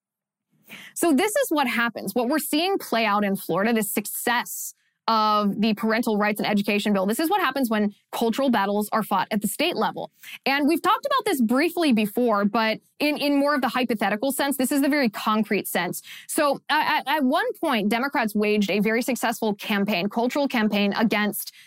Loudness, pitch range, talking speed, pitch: -23 LUFS, 210-280 Hz, 190 wpm, 230 Hz